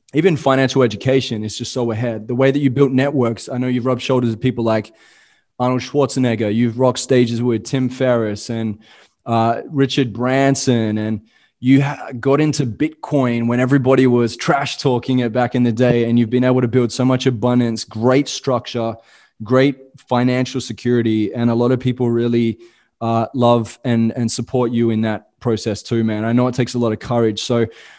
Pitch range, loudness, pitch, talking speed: 115-130 Hz, -17 LUFS, 125 Hz, 180 wpm